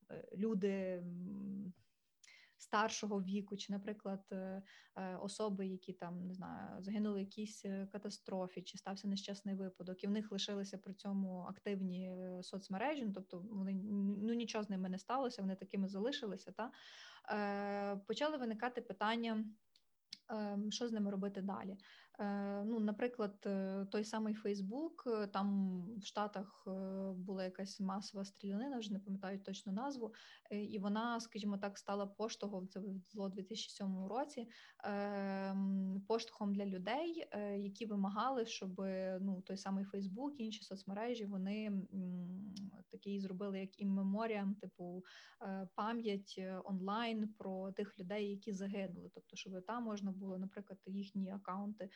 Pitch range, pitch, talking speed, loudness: 195-215 Hz, 200 Hz, 125 wpm, -43 LUFS